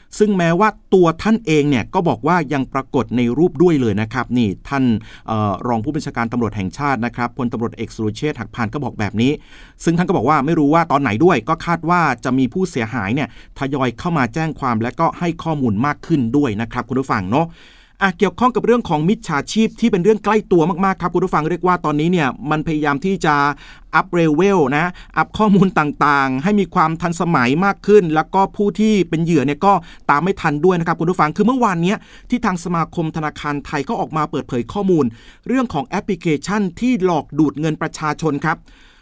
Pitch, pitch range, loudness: 160 Hz, 135-185 Hz, -17 LUFS